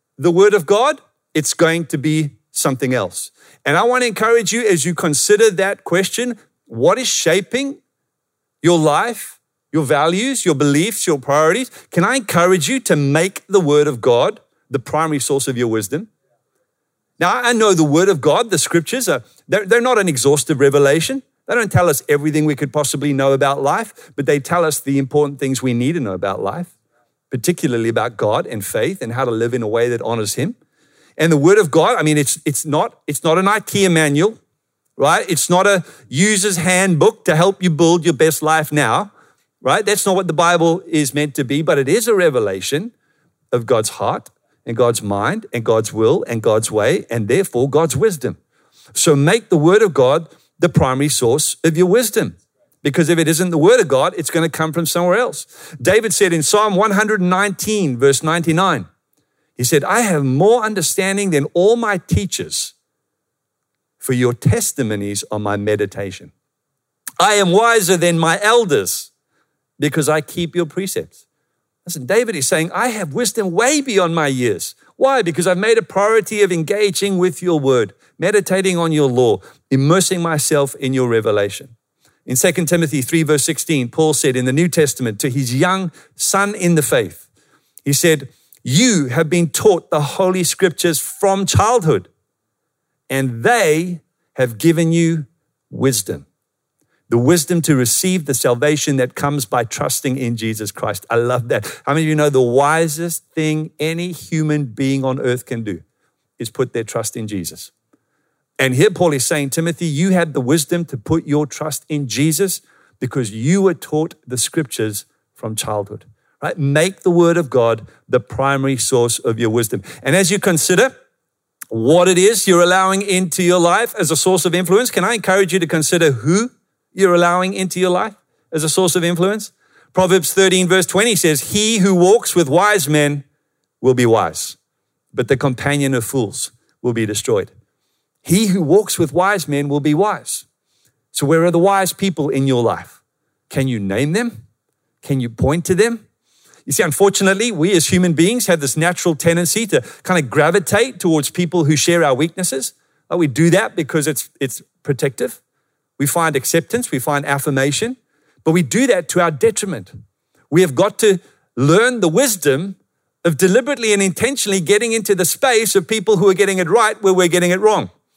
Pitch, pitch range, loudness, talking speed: 165 Hz, 140-190 Hz, -16 LUFS, 185 wpm